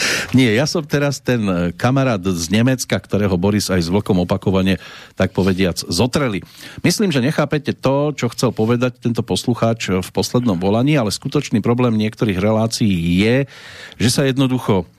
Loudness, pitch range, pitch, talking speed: -17 LUFS, 95-130 Hz, 115 Hz, 150 wpm